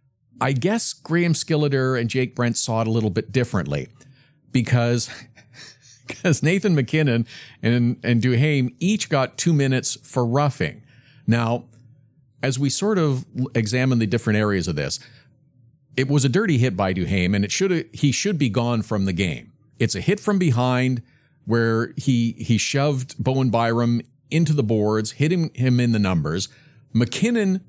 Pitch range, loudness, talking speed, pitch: 115-145 Hz, -21 LUFS, 160 wpm, 130 Hz